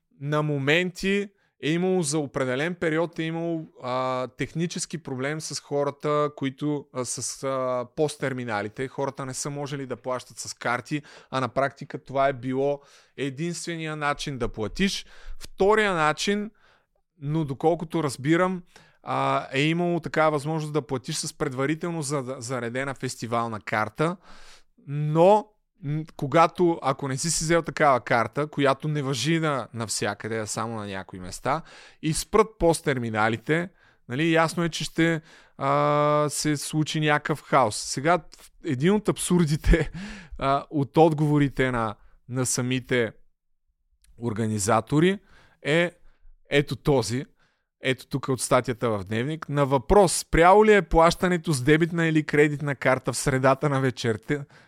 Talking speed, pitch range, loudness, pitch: 130 wpm, 130-165 Hz, -25 LUFS, 145 Hz